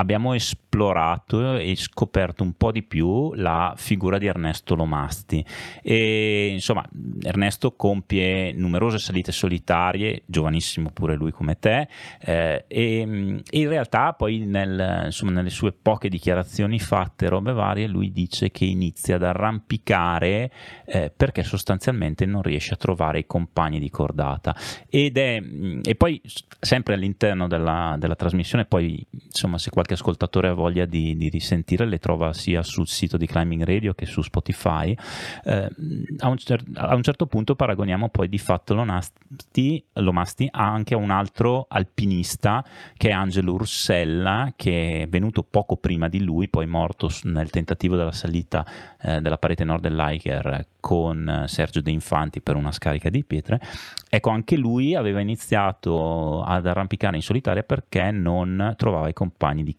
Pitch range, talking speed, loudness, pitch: 85-110 Hz, 155 wpm, -23 LUFS, 95 Hz